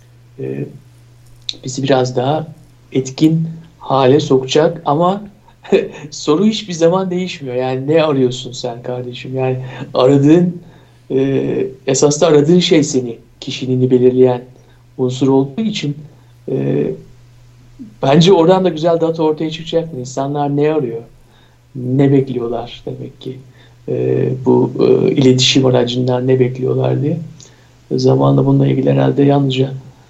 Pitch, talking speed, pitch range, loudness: 130 Hz, 115 wpm, 120-150 Hz, -14 LUFS